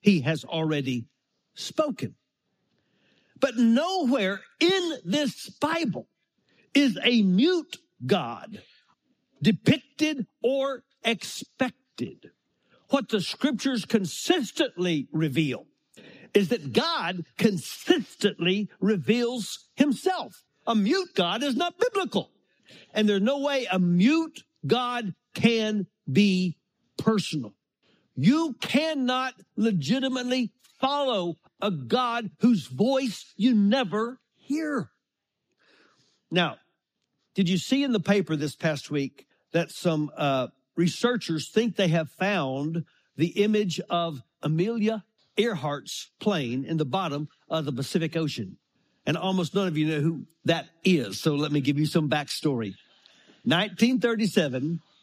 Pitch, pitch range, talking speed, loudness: 205 Hz, 165-250 Hz, 110 wpm, -26 LUFS